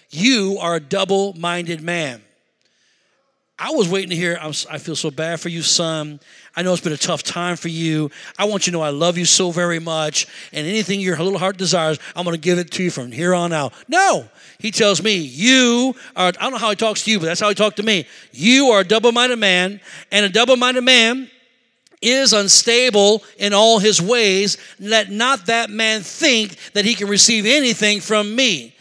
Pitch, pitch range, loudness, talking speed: 195 Hz, 170-225 Hz, -16 LUFS, 225 wpm